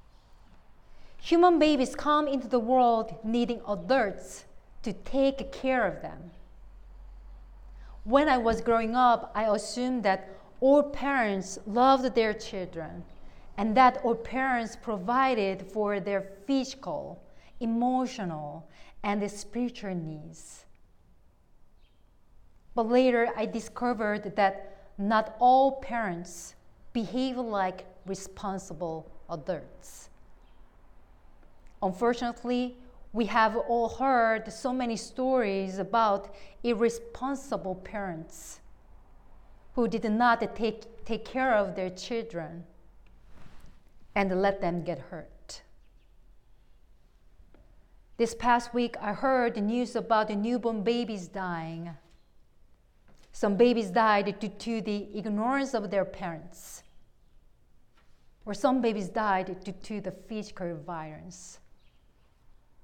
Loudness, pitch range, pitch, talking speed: -28 LUFS, 195-240 Hz, 220 Hz, 100 wpm